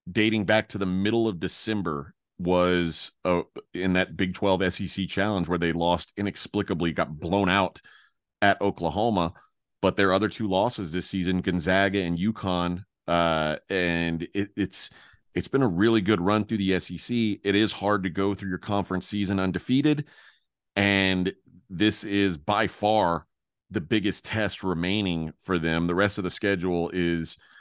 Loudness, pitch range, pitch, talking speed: -26 LUFS, 90-100 Hz, 95 Hz, 160 wpm